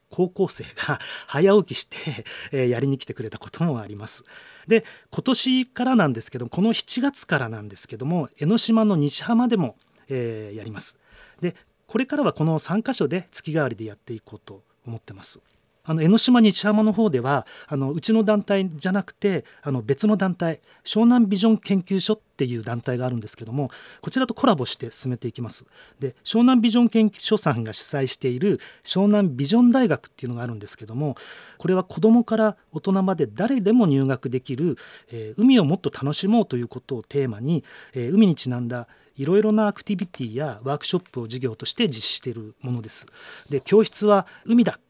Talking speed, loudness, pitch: 390 characters per minute, -22 LUFS, 160 Hz